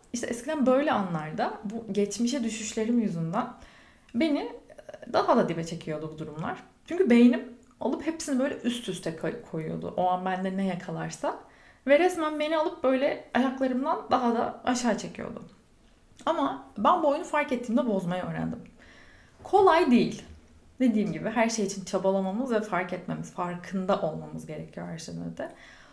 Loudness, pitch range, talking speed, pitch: -28 LUFS, 180-260 Hz, 145 wpm, 225 Hz